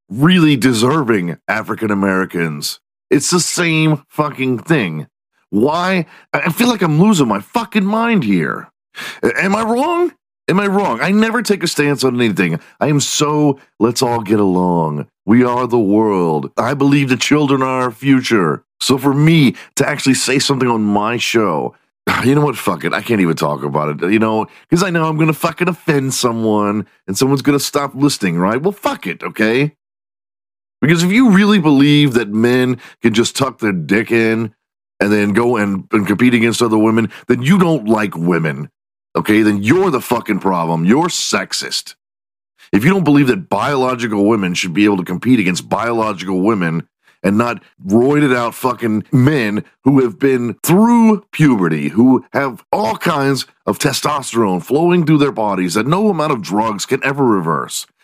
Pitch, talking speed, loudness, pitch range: 125 Hz, 180 wpm, -15 LUFS, 105-150 Hz